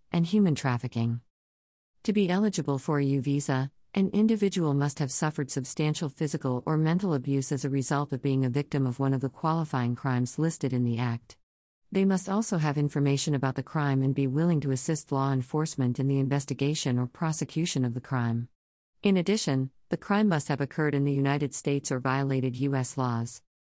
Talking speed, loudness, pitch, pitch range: 190 wpm, -28 LUFS, 140 Hz, 130-155 Hz